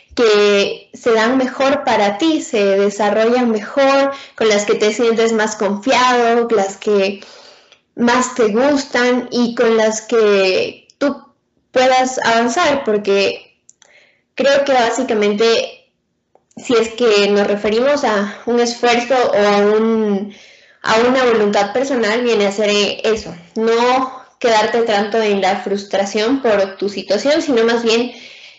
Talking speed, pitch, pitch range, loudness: 135 wpm, 230 Hz, 205-255 Hz, -15 LUFS